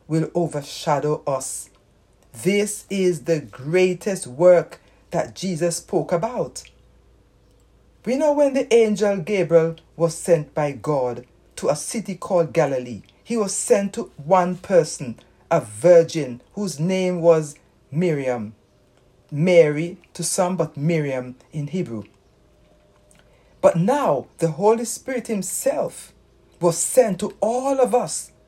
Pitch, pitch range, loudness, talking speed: 170 Hz, 135-190 Hz, -21 LUFS, 120 wpm